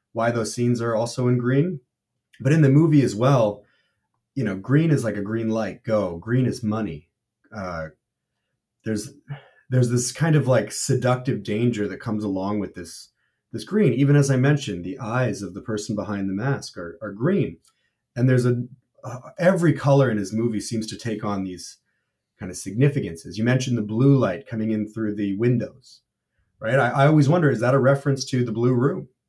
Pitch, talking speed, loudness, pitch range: 120 Hz, 195 wpm, -22 LUFS, 105-135 Hz